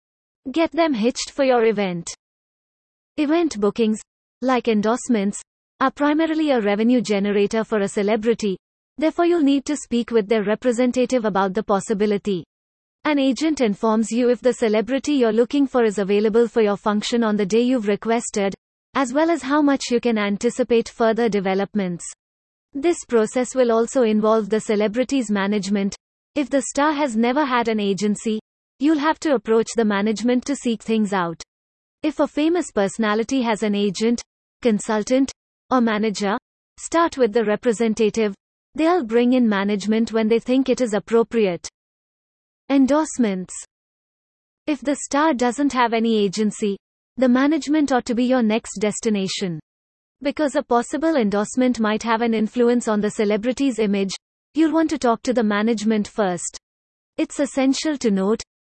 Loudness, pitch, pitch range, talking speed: -20 LUFS, 230 Hz, 215-265 Hz, 150 wpm